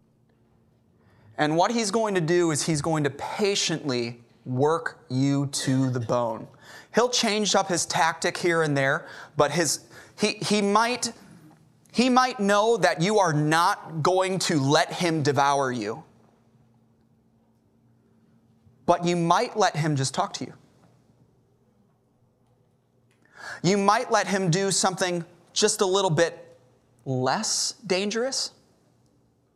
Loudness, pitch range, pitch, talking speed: -24 LUFS, 125-195 Hz, 160 Hz, 130 wpm